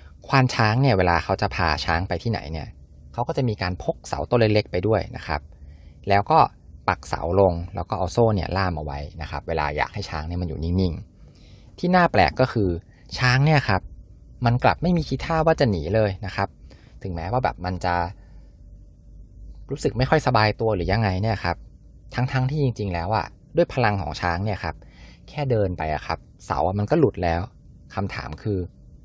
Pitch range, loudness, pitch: 85-115 Hz, -23 LUFS, 95 Hz